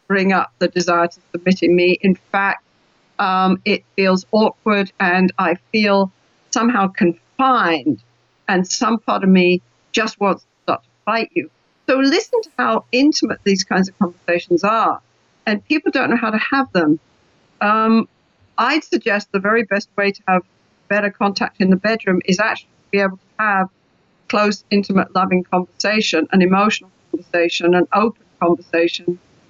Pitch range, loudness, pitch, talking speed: 180-220 Hz, -17 LUFS, 195 Hz, 165 wpm